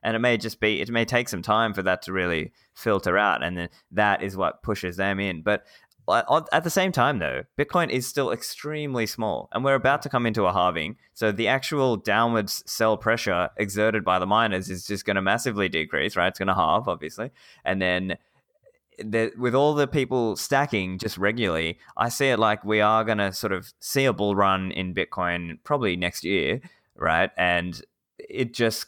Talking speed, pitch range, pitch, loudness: 205 wpm, 95-125 Hz, 110 Hz, -24 LUFS